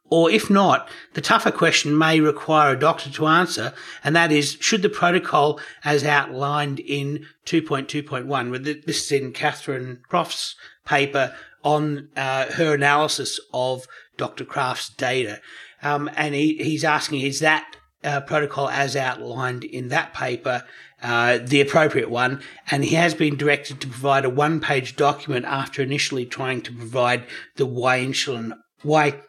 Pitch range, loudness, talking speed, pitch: 130-155 Hz, -21 LUFS, 150 wpm, 145 Hz